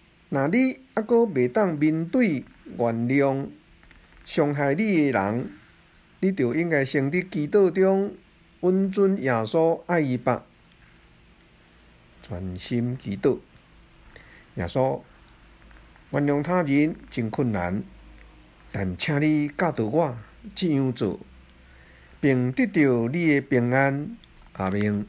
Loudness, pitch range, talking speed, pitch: -24 LUFS, 105-170 Hz, 150 characters per minute, 140 Hz